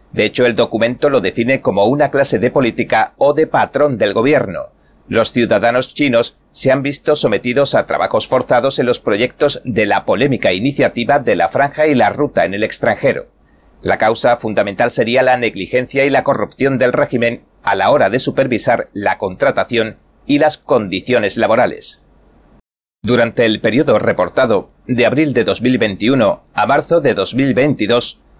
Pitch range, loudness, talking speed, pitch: 115-140 Hz, -14 LUFS, 160 wpm, 130 Hz